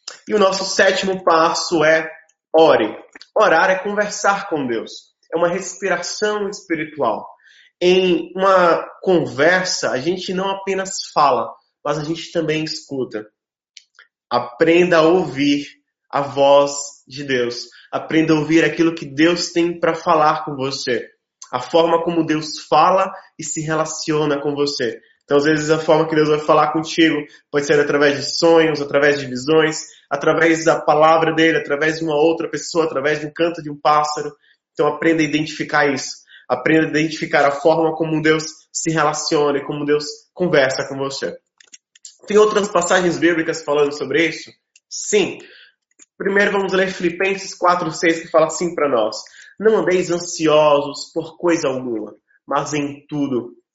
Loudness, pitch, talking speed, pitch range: -17 LUFS, 160 Hz, 155 wpm, 150-175 Hz